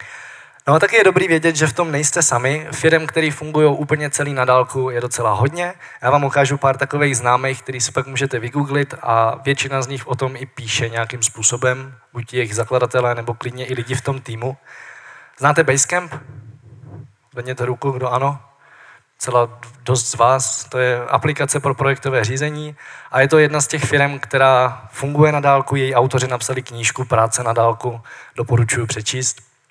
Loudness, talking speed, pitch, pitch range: -17 LUFS, 180 wpm, 130 Hz, 120-140 Hz